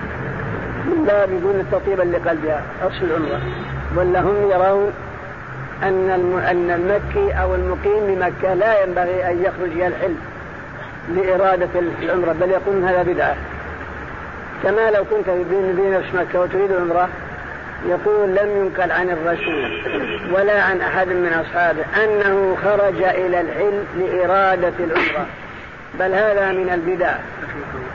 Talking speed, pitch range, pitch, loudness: 115 wpm, 175-195 Hz, 185 Hz, -18 LUFS